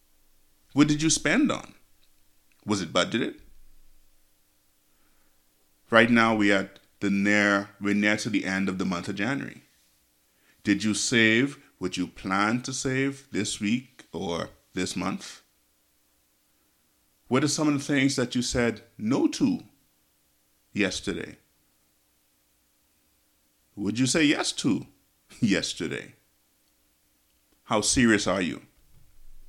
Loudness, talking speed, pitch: -25 LUFS, 120 wpm, 85 Hz